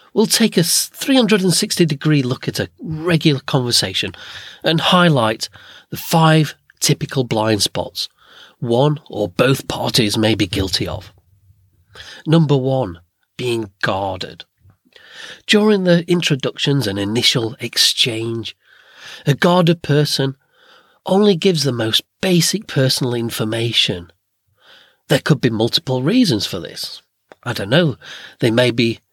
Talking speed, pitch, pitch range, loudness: 120 wpm, 135 Hz, 110-165 Hz, -16 LUFS